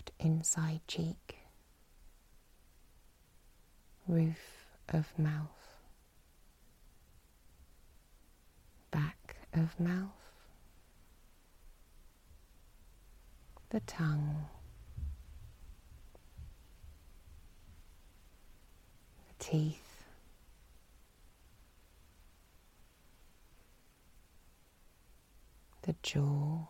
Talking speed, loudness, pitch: 30 wpm, -37 LUFS, 85 Hz